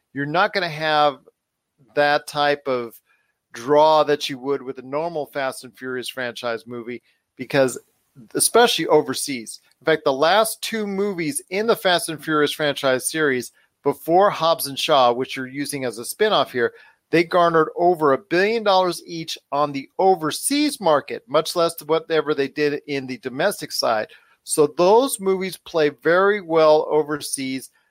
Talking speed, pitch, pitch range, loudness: 160 wpm, 150 Hz, 135-170 Hz, -20 LUFS